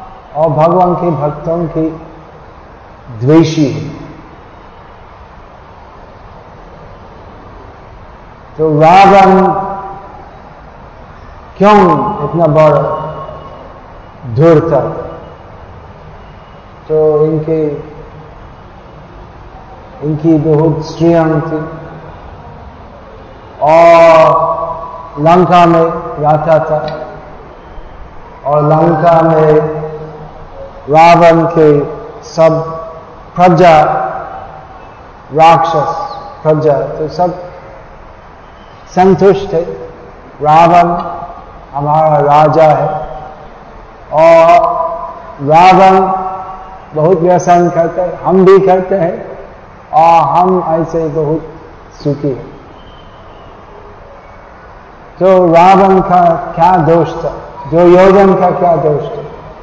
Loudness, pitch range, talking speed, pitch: -9 LUFS, 150-175 Hz, 70 wpm, 160 Hz